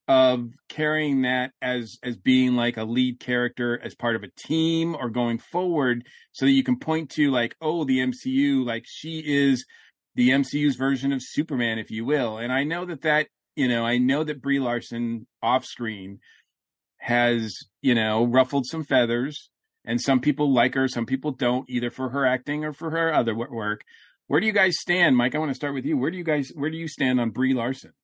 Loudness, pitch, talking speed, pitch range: -24 LUFS, 130 Hz, 210 wpm, 120-150 Hz